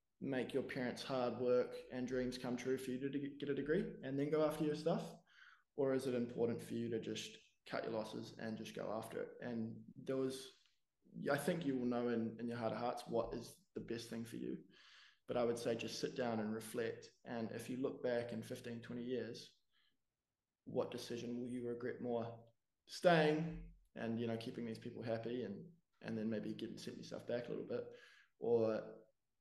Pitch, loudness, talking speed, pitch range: 120 Hz, -42 LUFS, 210 wpm, 115-135 Hz